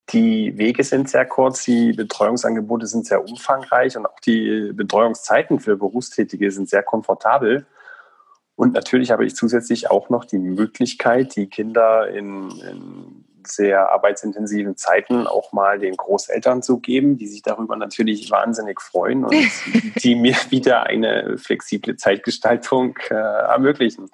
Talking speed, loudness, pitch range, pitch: 140 wpm, -18 LUFS, 105-130 Hz, 120 Hz